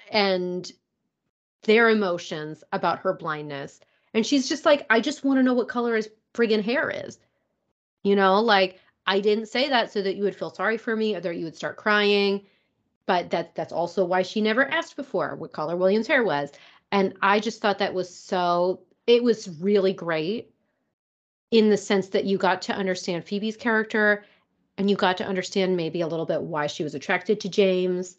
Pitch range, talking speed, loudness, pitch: 180-220 Hz, 195 wpm, -24 LUFS, 200 Hz